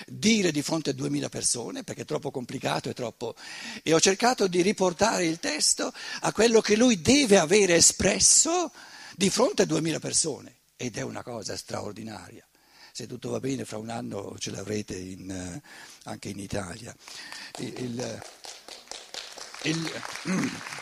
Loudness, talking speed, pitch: -25 LUFS, 150 wpm, 155 Hz